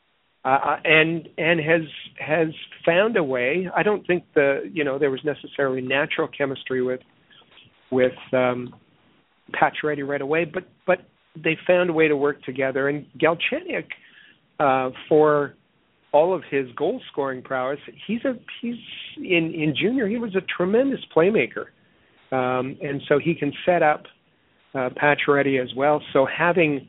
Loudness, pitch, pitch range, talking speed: -22 LUFS, 150 Hz, 135-170 Hz, 150 wpm